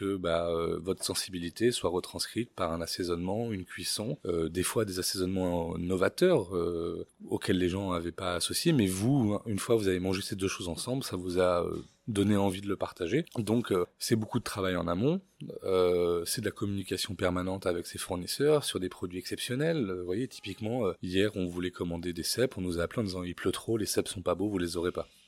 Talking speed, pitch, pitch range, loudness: 225 wpm, 95 Hz, 90-110 Hz, -31 LUFS